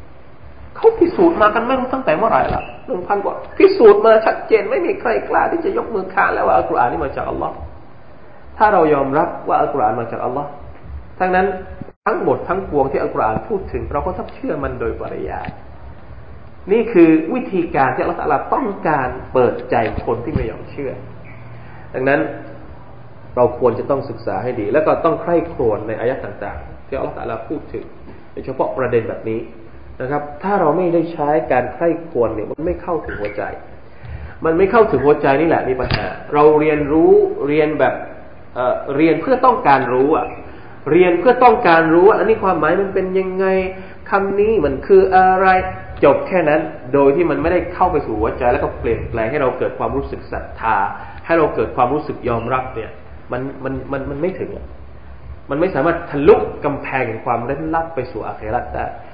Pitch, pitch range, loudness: 160 Hz, 130-195 Hz, -17 LUFS